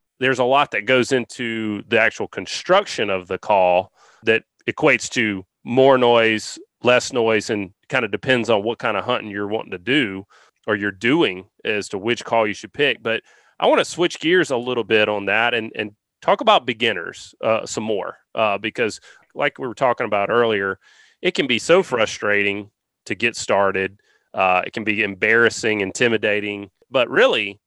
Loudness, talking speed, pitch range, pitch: -19 LUFS, 185 wpm, 100-115 Hz, 105 Hz